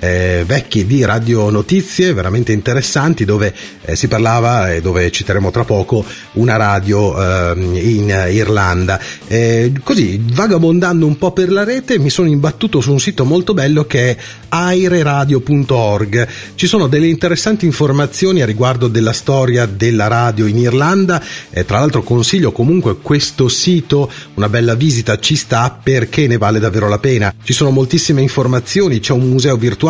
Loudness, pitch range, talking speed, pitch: -13 LUFS, 110-150 Hz, 160 wpm, 125 Hz